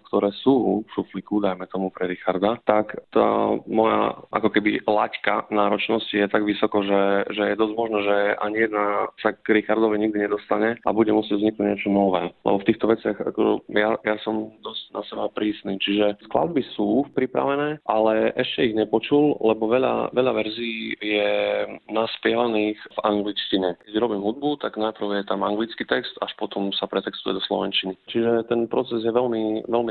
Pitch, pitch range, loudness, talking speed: 105 Hz, 100-110 Hz, -23 LUFS, 170 wpm